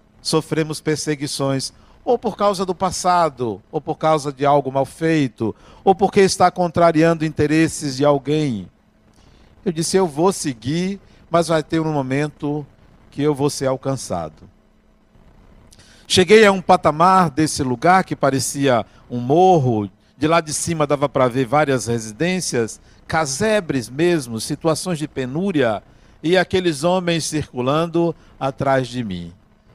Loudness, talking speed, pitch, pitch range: -19 LUFS, 135 wpm, 150 Hz, 135-170 Hz